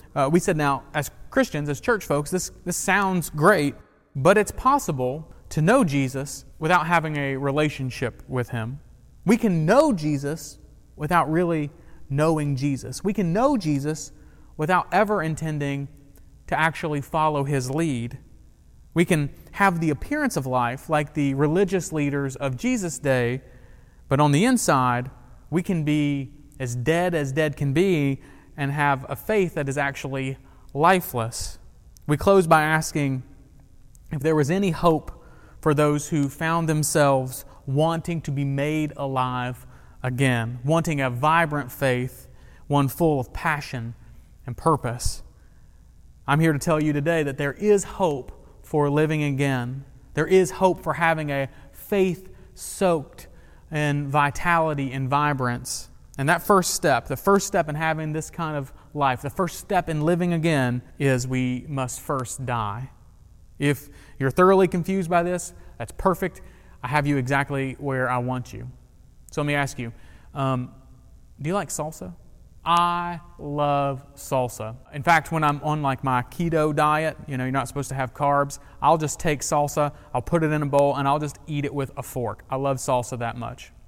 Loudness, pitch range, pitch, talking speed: -23 LUFS, 130-165 Hz, 145 Hz, 165 wpm